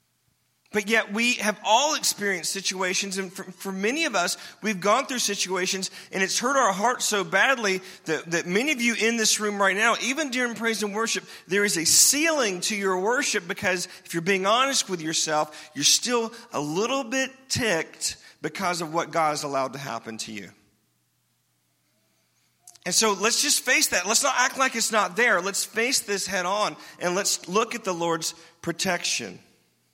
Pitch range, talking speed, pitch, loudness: 180-230 Hz, 190 wpm, 200 Hz, -23 LUFS